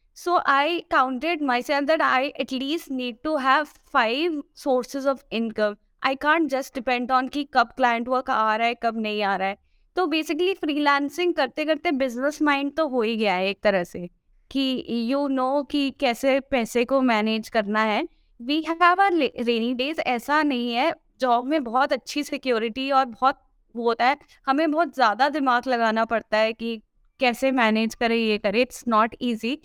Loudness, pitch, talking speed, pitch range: -23 LUFS, 260 Hz, 190 wpm, 235-290 Hz